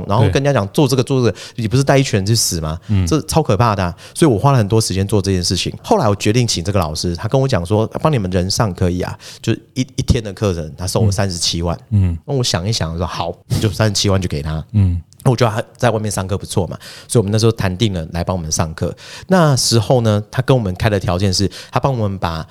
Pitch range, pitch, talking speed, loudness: 90-120 Hz, 105 Hz, 385 characters per minute, -17 LUFS